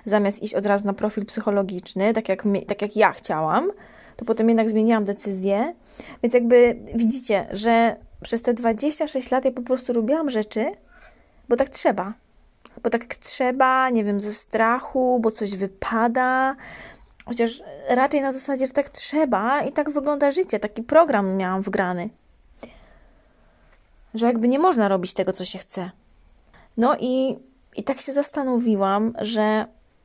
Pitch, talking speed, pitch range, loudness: 230 Hz, 150 wpm, 205-260 Hz, -22 LUFS